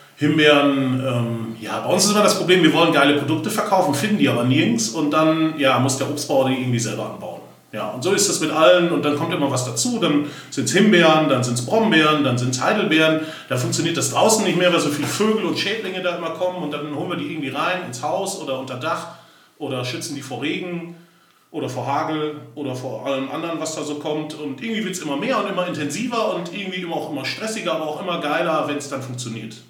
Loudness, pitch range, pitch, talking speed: -20 LUFS, 135-170 Hz, 155 Hz, 240 wpm